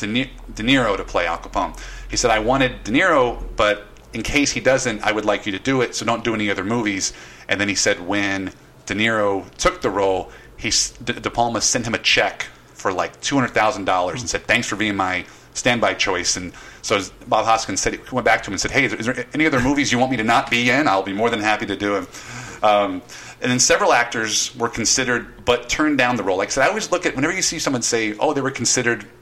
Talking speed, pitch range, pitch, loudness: 245 wpm, 105-125 Hz, 115 Hz, -19 LUFS